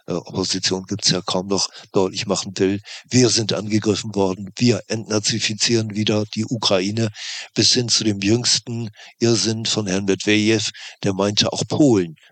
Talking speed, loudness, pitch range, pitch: 150 wpm, -19 LUFS, 100-115 Hz, 110 Hz